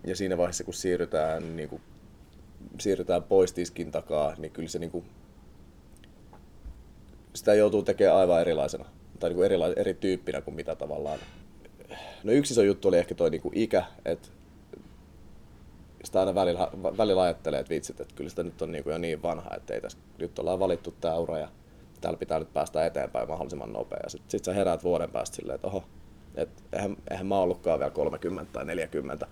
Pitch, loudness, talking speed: 90 Hz, -29 LUFS, 185 wpm